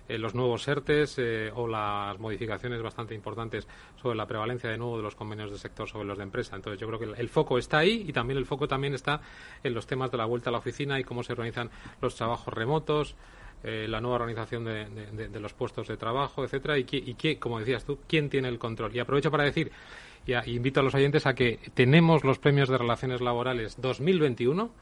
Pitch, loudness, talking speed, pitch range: 120 Hz, -29 LUFS, 235 wpm, 115-135 Hz